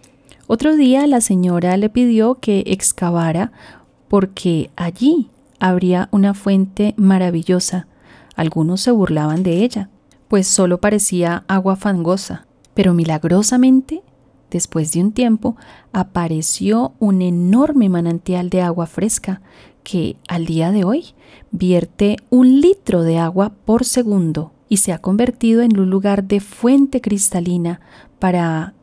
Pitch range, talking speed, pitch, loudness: 175-225 Hz, 125 wpm, 195 Hz, -16 LUFS